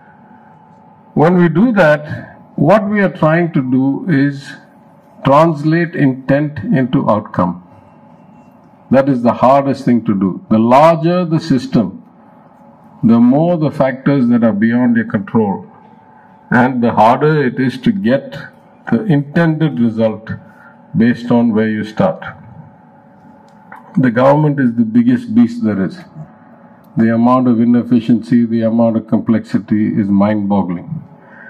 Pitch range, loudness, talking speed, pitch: 115-175 Hz, -13 LUFS, 130 wpm, 135 Hz